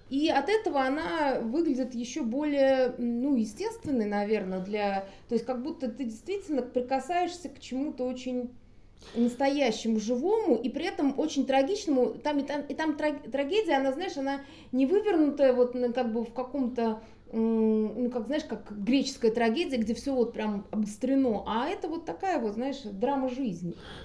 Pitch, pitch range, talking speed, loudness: 260 Hz, 235-285 Hz, 160 wpm, -29 LUFS